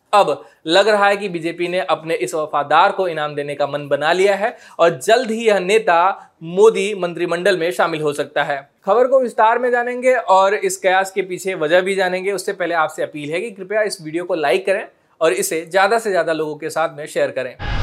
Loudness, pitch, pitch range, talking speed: -17 LUFS, 180 Hz, 155-200 Hz, 220 wpm